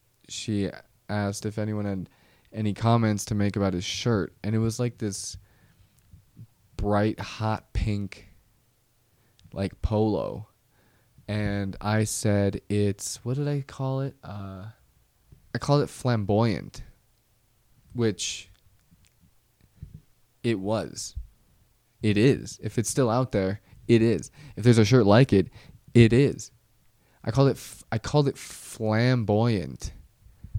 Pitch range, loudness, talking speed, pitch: 100-120 Hz, -26 LUFS, 125 wpm, 110 Hz